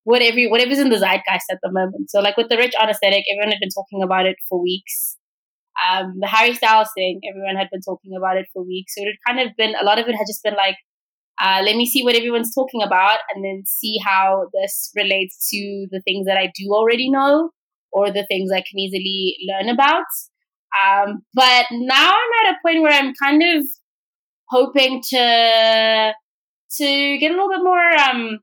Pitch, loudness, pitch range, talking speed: 220 Hz, -17 LUFS, 195-265 Hz, 210 wpm